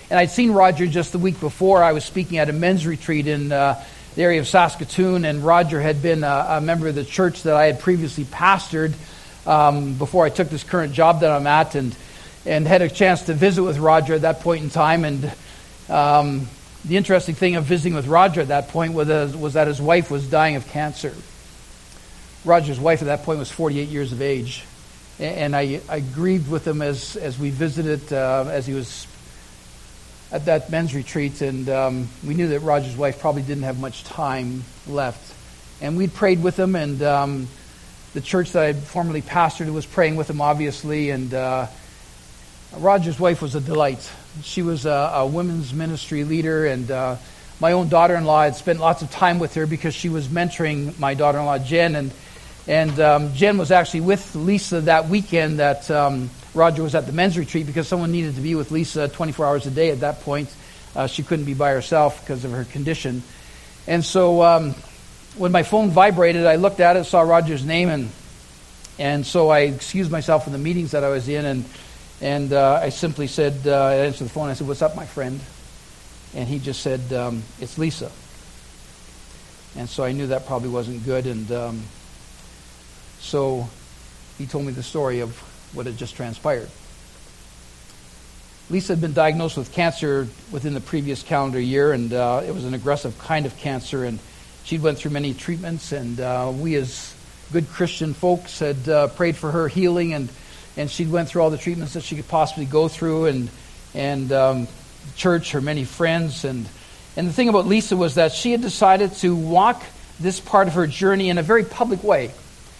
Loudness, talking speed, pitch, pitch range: -20 LUFS, 200 wpm, 150 Hz, 135-165 Hz